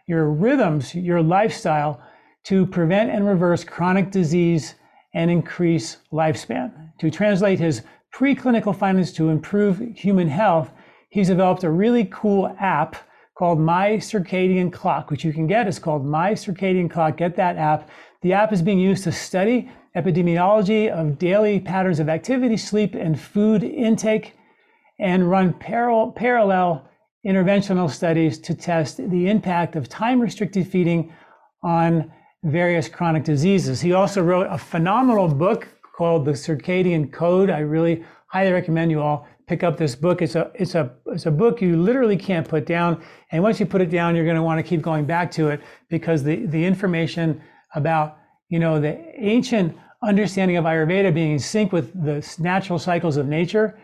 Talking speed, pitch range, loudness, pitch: 165 wpm, 160-195 Hz, -20 LUFS, 175 Hz